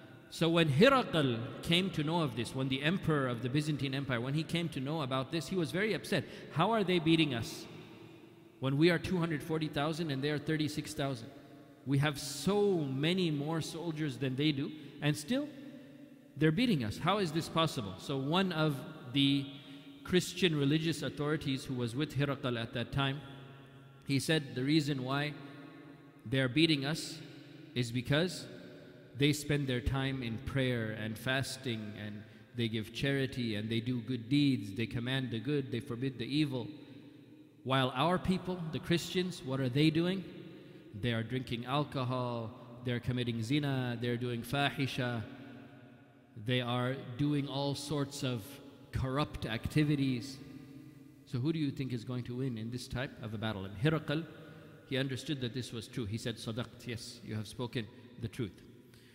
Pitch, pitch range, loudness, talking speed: 140 Hz, 125-155 Hz, -34 LUFS, 165 wpm